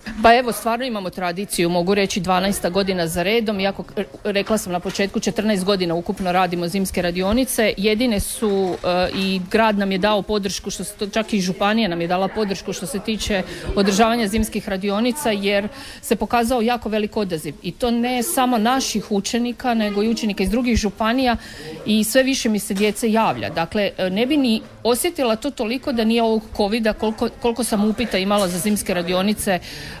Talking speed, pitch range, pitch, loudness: 180 wpm, 195-230 Hz, 210 Hz, -20 LUFS